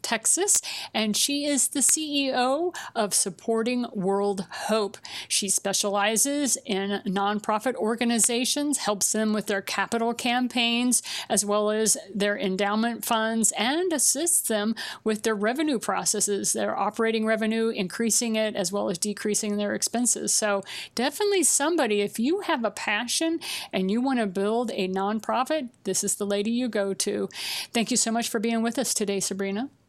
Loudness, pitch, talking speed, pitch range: -25 LUFS, 220 Hz, 155 wpm, 205-245 Hz